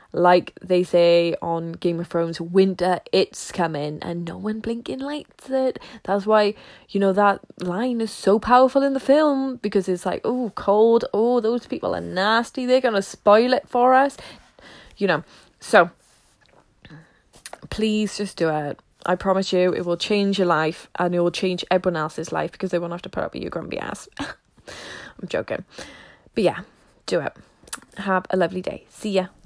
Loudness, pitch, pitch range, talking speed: -22 LUFS, 195 Hz, 175-230 Hz, 185 wpm